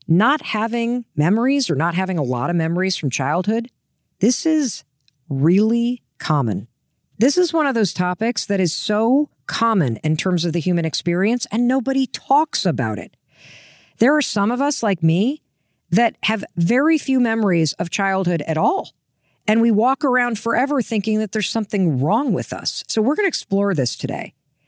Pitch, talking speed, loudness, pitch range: 215 Hz, 175 wpm, -19 LUFS, 170-245 Hz